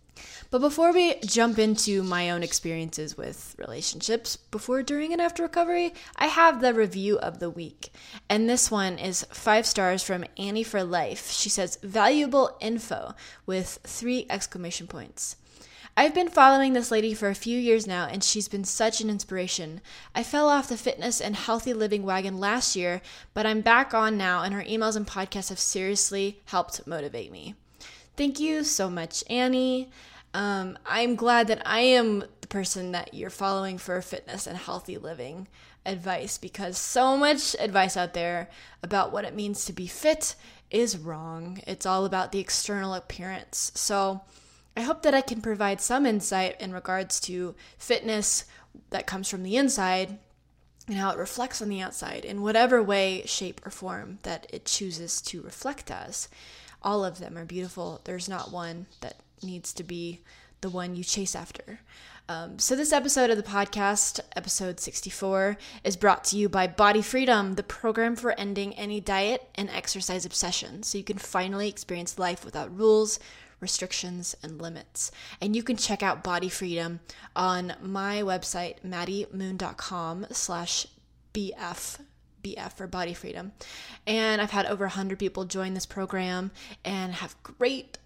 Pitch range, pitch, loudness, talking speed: 185-225 Hz, 200 Hz, -27 LUFS, 165 wpm